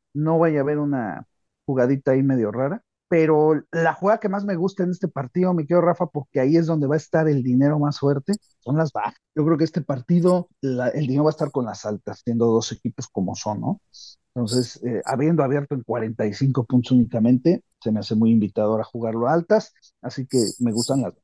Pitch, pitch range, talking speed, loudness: 140 Hz, 120-160 Hz, 225 wpm, -22 LUFS